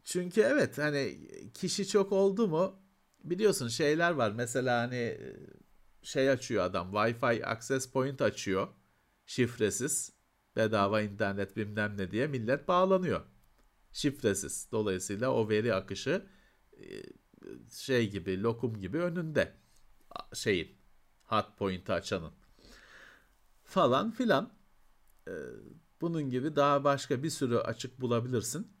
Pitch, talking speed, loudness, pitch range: 130 Hz, 105 wpm, -32 LUFS, 110-165 Hz